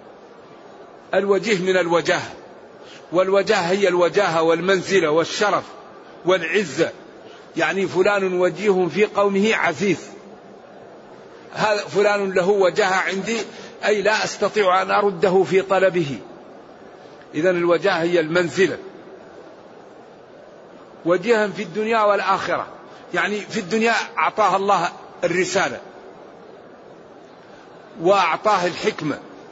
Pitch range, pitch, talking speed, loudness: 180-205 Hz, 190 Hz, 85 wpm, -19 LUFS